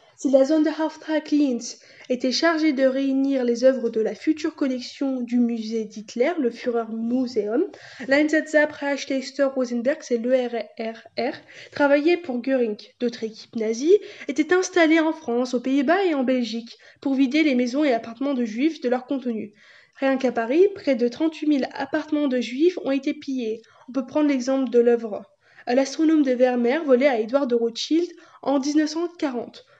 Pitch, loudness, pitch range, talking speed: 270 Hz, -23 LUFS, 240-300 Hz, 160 wpm